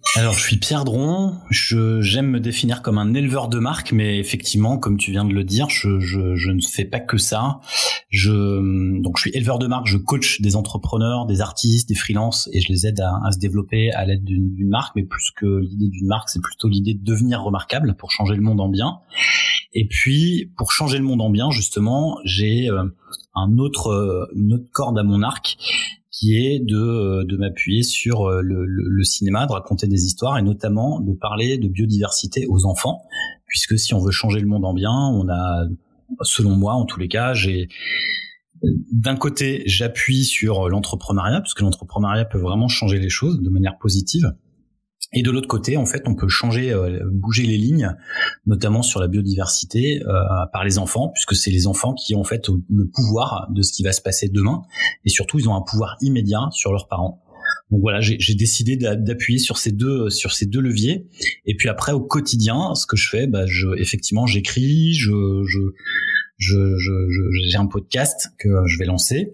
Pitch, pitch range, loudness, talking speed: 105 Hz, 95-125 Hz, -19 LUFS, 205 wpm